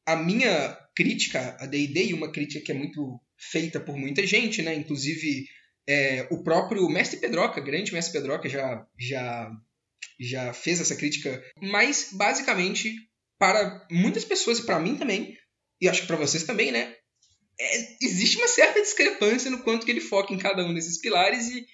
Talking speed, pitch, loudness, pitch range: 175 wpm, 165 Hz, -25 LUFS, 140-205 Hz